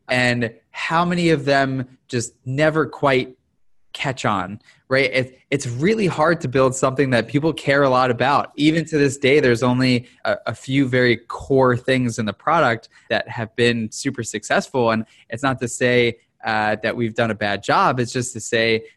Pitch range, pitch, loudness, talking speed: 120-140 Hz, 130 Hz, -19 LUFS, 185 wpm